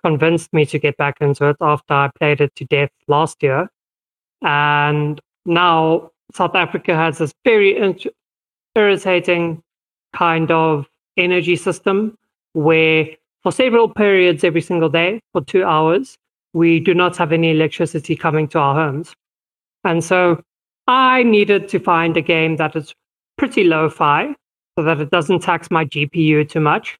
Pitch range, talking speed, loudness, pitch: 155-180 Hz, 155 wpm, -16 LUFS, 165 Hz